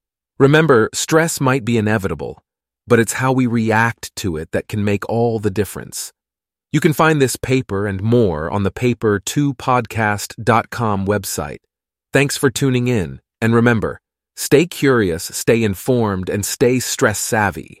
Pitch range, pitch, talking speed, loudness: 100-130 Hz, 115 Hz, 145 wpm, -17 LUFS